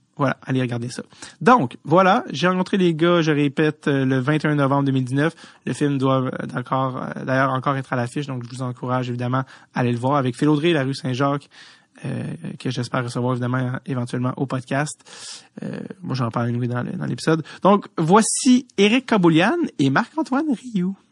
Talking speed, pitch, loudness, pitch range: 170 wpm, 140 Hz, -21 LUFS, 130-165 Hz